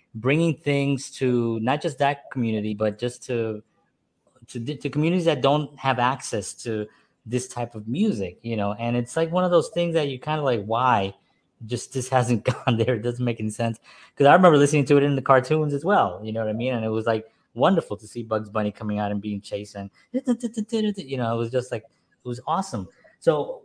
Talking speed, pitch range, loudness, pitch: 225 wpm, 110-145 Hz, -24 LUFS, 125 Hz